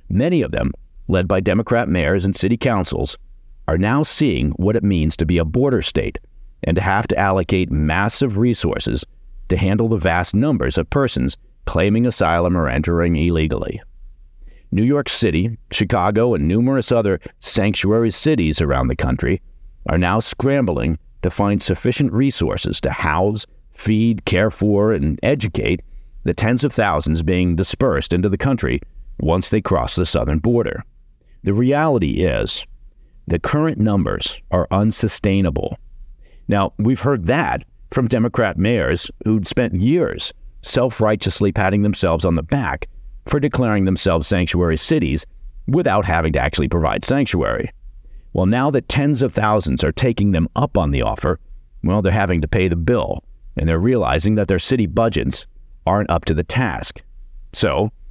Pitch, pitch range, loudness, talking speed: 95 Hz, 80-115 Hz, -18 LUFS, 155 wpm